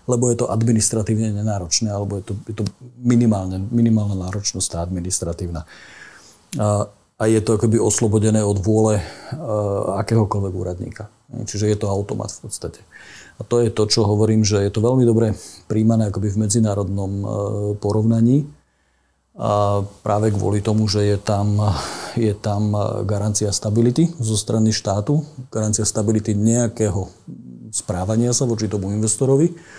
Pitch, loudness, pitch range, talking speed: 105 Hz, -20 LUFS, 100-115 Hz, 135 wpm